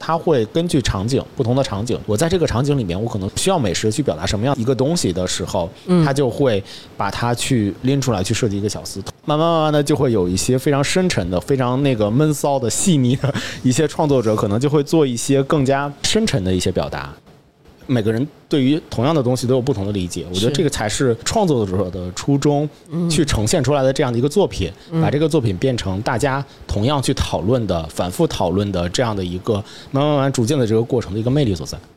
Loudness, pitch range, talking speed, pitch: -18 LUFS, 105-145 Hz, 350 characters per minute, 130 Hz